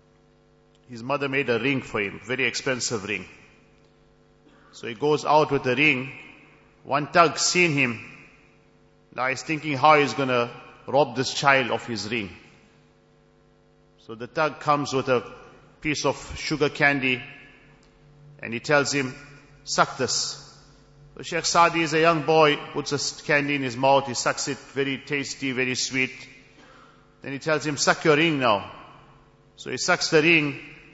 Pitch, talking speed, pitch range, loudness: 145 Hz, 160 wpm, 130-150 Hz, -23 LUFS